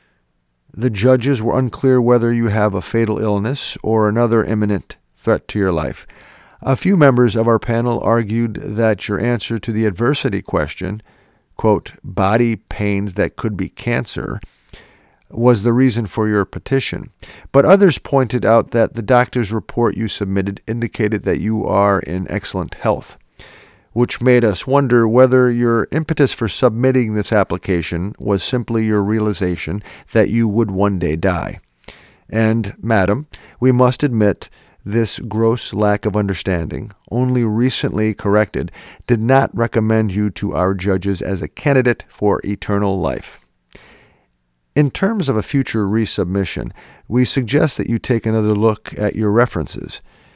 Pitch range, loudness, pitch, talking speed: 100-120 Hz, -17 LUFS, 110 Hz, 150 wpm